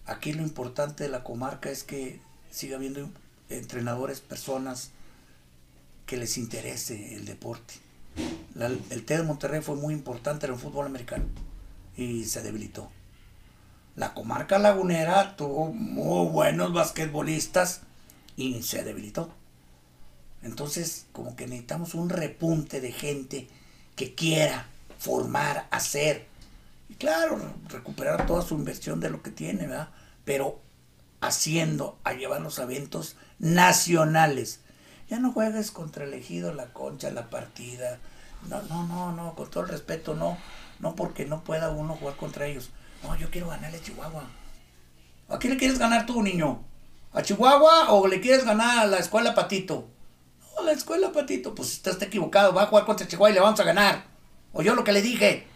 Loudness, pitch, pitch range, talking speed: -26 LUFS, 145 Hz, 115-185 Hz, 155 wpm